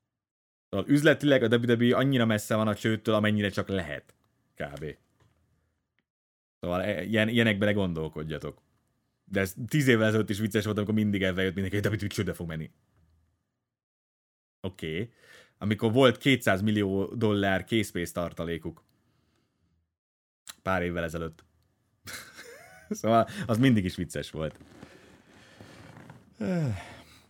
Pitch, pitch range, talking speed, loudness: 105 Hz, 85-115 Hz, 120 wpm, -27 LUFS